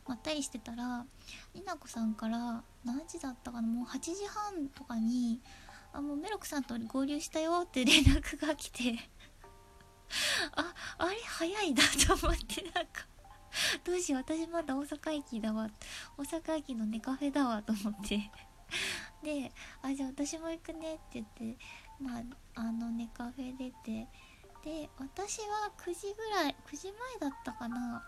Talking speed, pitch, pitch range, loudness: 280 characters per minute, 280 Hz, 240-325 Hz, -35 LUFS